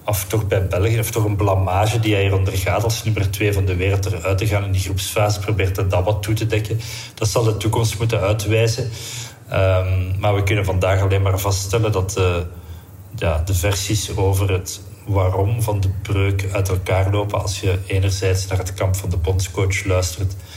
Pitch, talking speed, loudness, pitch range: 100 Hz, 200 wpm, -19 LUFS, 95-105 Hz